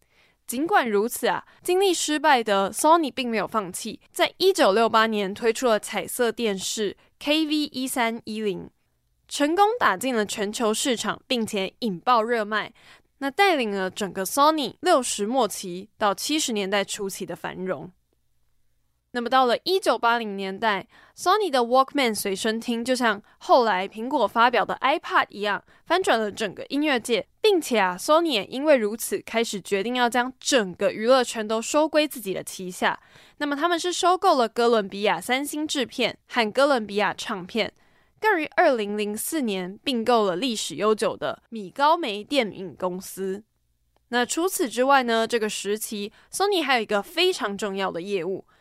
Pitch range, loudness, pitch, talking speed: 205-285 Hz, -23 LUFS, 230 Hz, 280 characters per minute